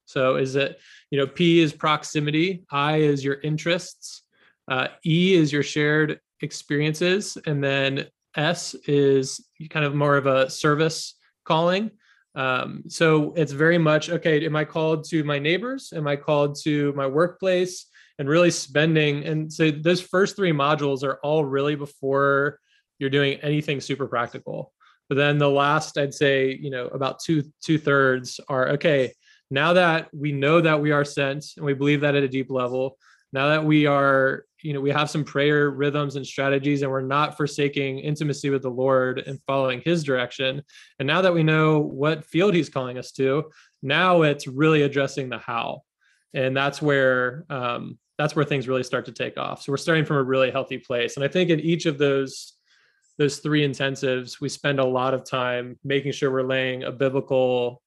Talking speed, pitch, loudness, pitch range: 185 wpm, 145 Hz, -23 LUFS, 135-155 Hz